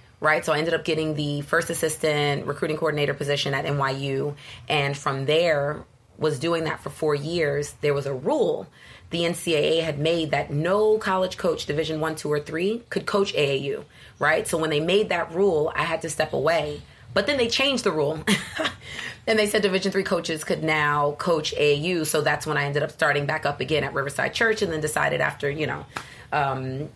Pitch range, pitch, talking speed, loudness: 145-170 Hz, 155 Hz, 205 wpm, -24 LUFS